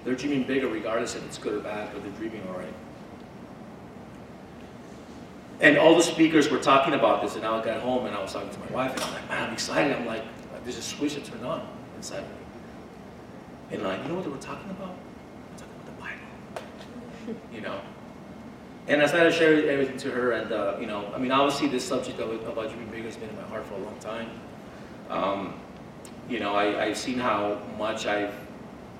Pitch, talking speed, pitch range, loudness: 125 Hz, 220 wpm, 110-150 Hz, -26 LUFS